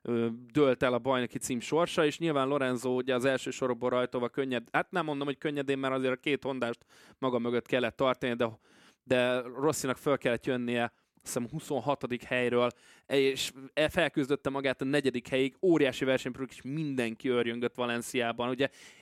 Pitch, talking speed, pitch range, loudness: 130 Hz, 165 wpm, 125-140 Hz, -31 LUFS